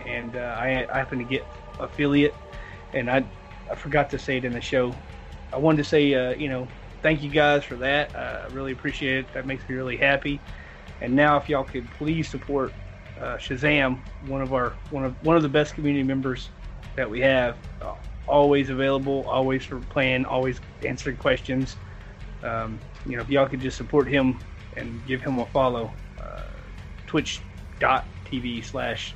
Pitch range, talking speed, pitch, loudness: 120-140 Hz, 180 wpm, 130 Hz, -25 LUFS